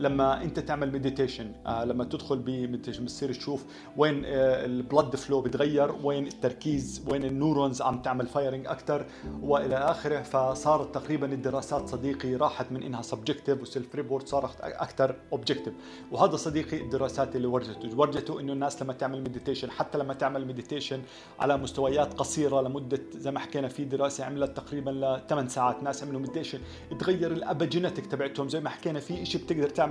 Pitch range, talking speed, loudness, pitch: 130-145 Hz, 155 wpm, -30 LUFS, 140 Hz